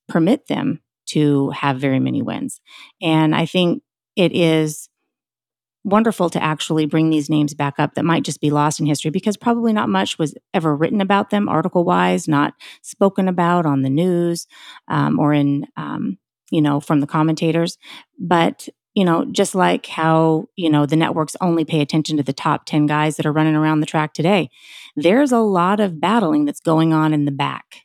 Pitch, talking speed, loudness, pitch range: 160 Hz, 190 wpm, -18 LUFS, 150-180 Hz